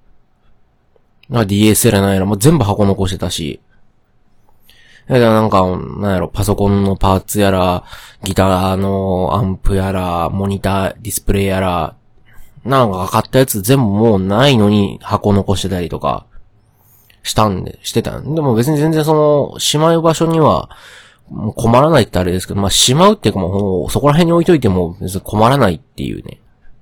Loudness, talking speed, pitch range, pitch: -14 LUFS, 335 characters per minute, 95-120 Hz, 105 Hz